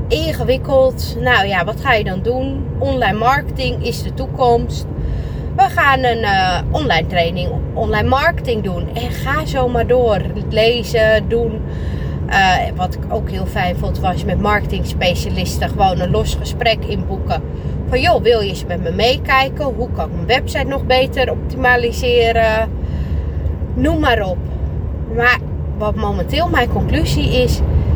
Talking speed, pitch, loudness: 150 wpm, 95 Hz, -16 LUFS